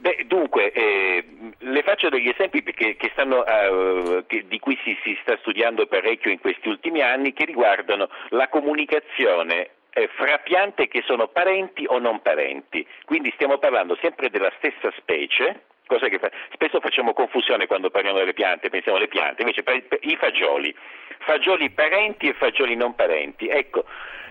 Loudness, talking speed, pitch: -21 LUFS, 165 wpm, 370 Hz